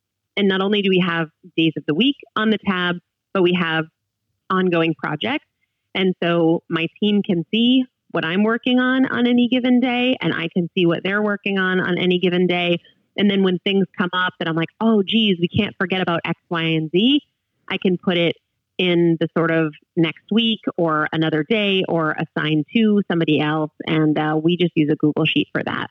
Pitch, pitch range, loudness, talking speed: 180 Hz, 165-205 Hz, -19 LUFS, 210 wpm